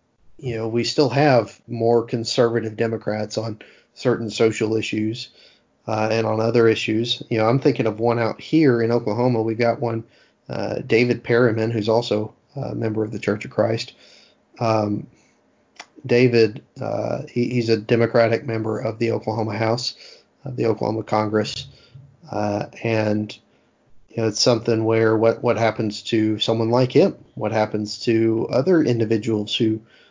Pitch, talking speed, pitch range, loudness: 115 Hz, 155 wpm, 110-120 Hz, -21 LUFS